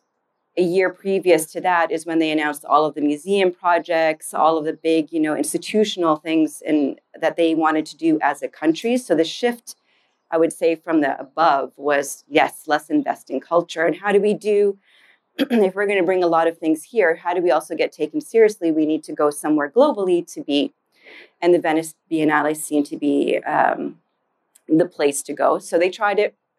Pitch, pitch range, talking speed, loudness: 165 Hz, 155-200 Hz, 205 wpm, -20 LUFS